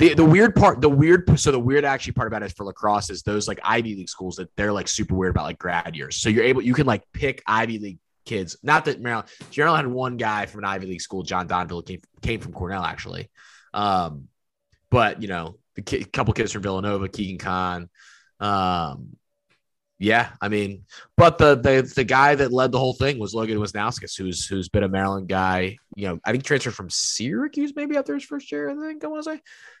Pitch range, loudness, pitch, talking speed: 95-140 Hz, -22 LUFS, 105 Hz, 230 wpm